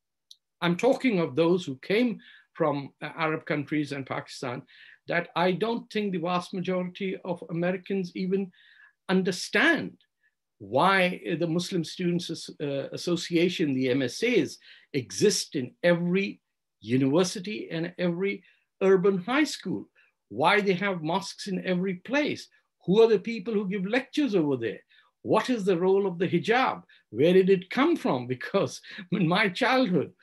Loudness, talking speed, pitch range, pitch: -27 LUFS, 145 wpm, 170-205 Hz, 185 Hz